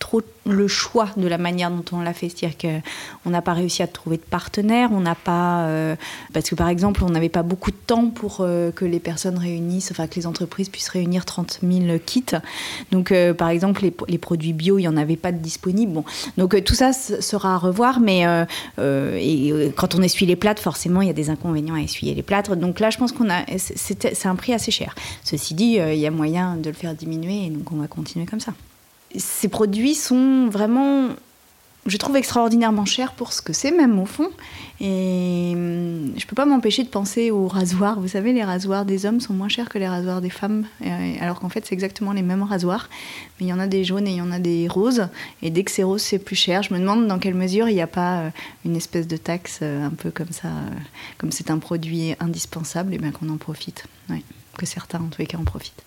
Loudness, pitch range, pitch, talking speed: -21 LUFS, 170-210 Hz, 185 Hz, 240 wpm